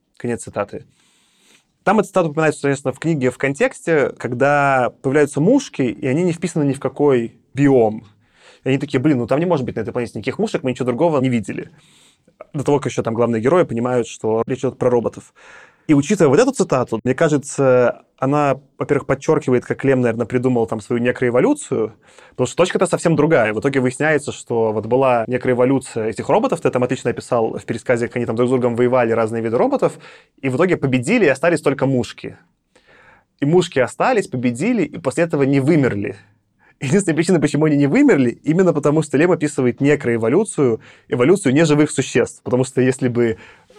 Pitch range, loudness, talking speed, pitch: 120-150 Hz, -18 LUFS, 190 wpm, 130 Hz